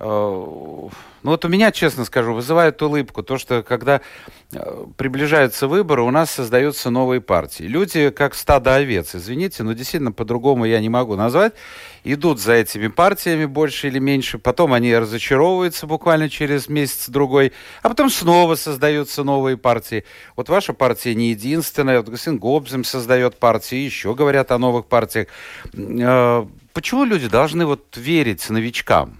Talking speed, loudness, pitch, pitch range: 145 wpm, -18 LUFS, 135 Hz, 120-150 Hz